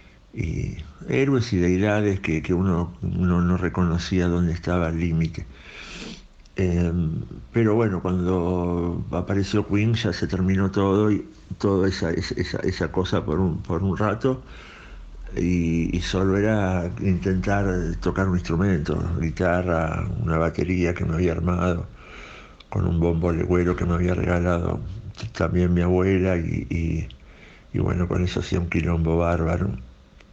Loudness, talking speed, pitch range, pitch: -23 LUFS, 140 wpm, 85-95 Hz, 90 Hz